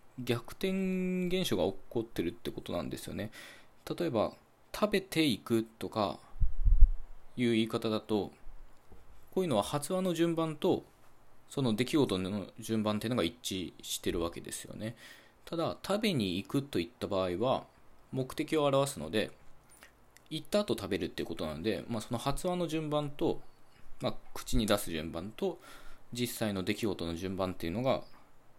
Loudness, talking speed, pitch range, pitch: -34 LUFS, 305 characters per minute, 105-155 Hz, 120 Hz